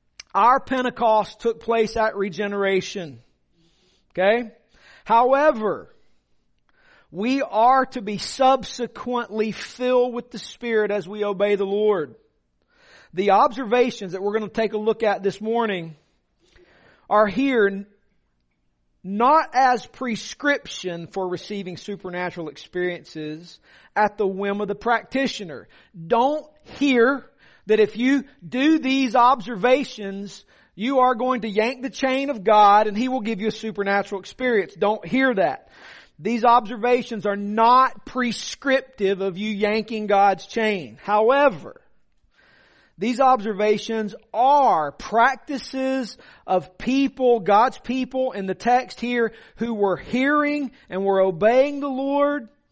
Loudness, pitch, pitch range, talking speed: -21 LUFS, 220 Hz, 200-255 Hz, 125 wpm